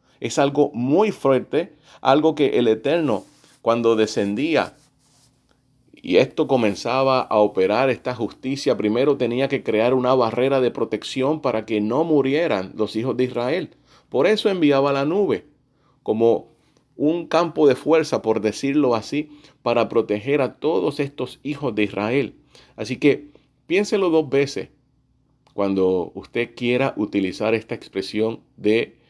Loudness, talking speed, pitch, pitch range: -21 LUFS, 135 wpm, 130 Hz, 110-140 Hz